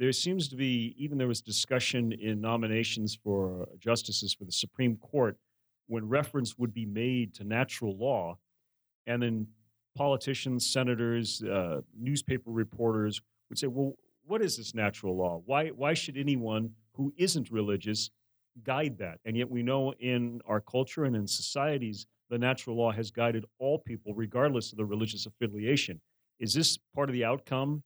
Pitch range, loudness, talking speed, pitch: 110-130 Hz, -32 LUFS, 165 wpm, 115 Hz